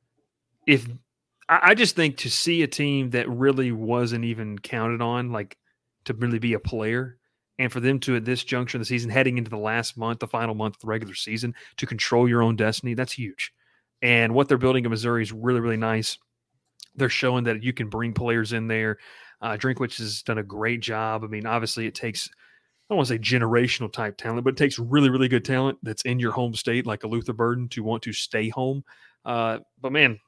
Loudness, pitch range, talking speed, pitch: -24 LUFS, 115-125 Hz, 220 wpm, 120 Hz